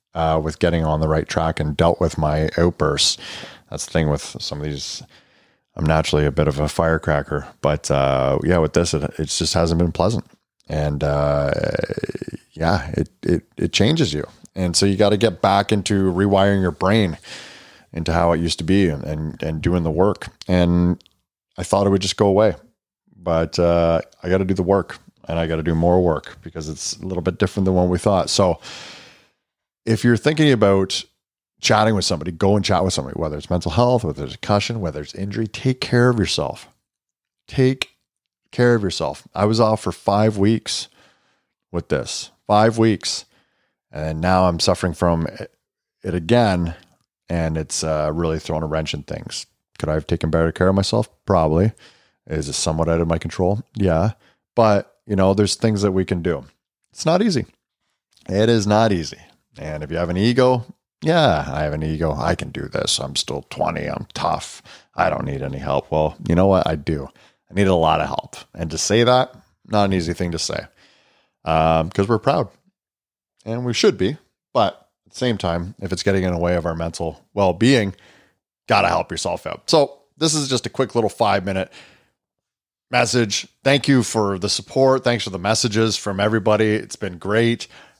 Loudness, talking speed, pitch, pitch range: -20 LUFS, 200 wpm, 90 Hz, 80-105 Hz